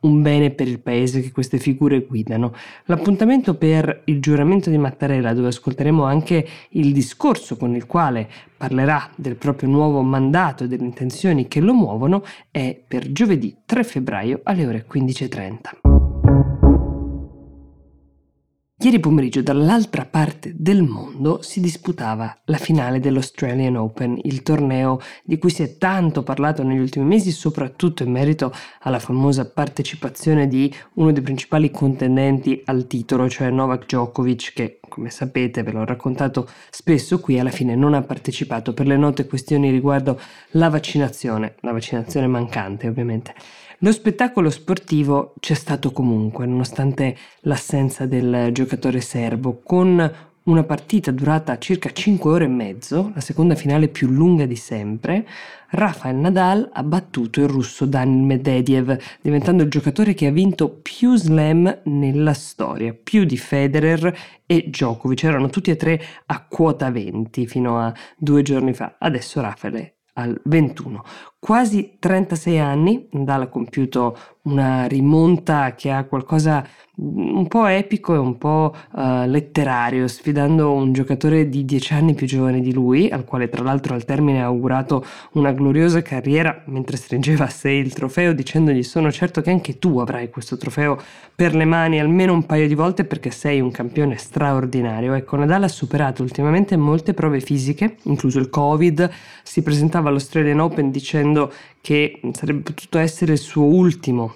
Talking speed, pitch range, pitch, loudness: 150 wpm, 130-160 Hz, 140 Hz, -19 LUFS